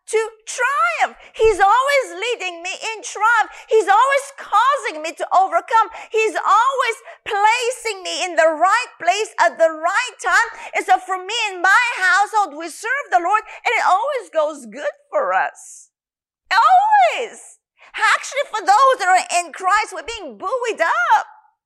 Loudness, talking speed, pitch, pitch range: -17 LUFS, 155 wpm, 400 Hz, 345-440 Hz